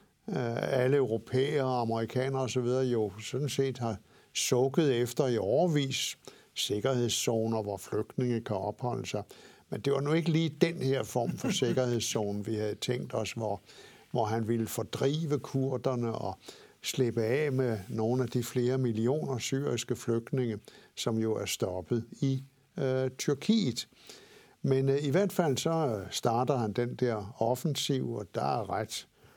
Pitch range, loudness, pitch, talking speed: 115-135 Hz, -31 LUFS, 125 Hz, 150 wpm